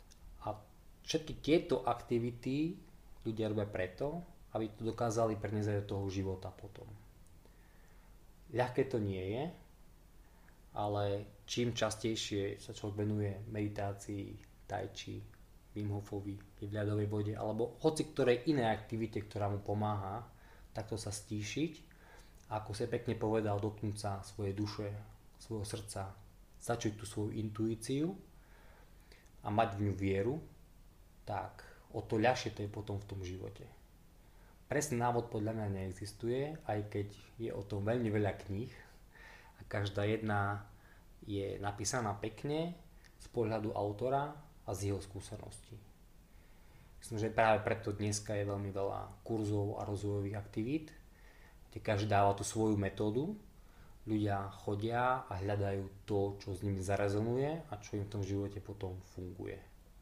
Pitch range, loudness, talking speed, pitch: 100-115 Hz, -38 LUFS, 130 wpm, 105 Hz